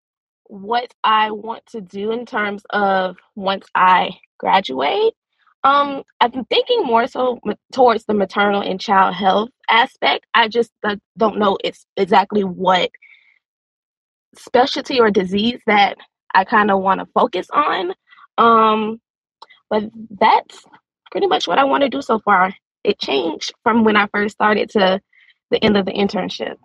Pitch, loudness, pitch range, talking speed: 220 Hz, -17 LUFS, 200-245 Hz, 155 wpm